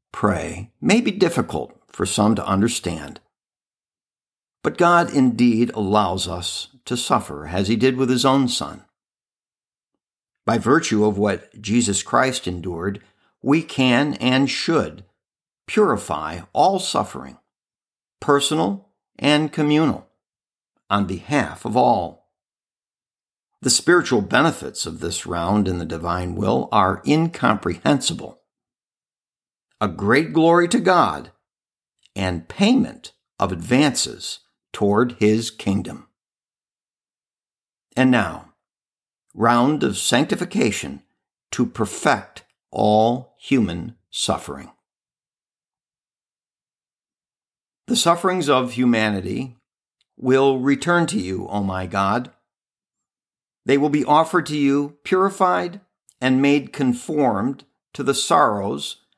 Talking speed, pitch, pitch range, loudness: 100 wpm, 125 Hz, 100-145 Hz, -20 LUFS